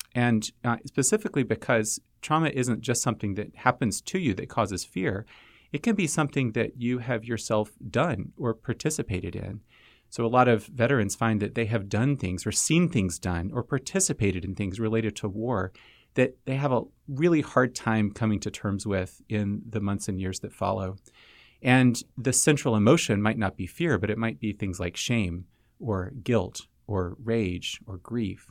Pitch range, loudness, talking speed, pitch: 100-125 Hz, -27 LUFS, 185 wpm, 115 Hz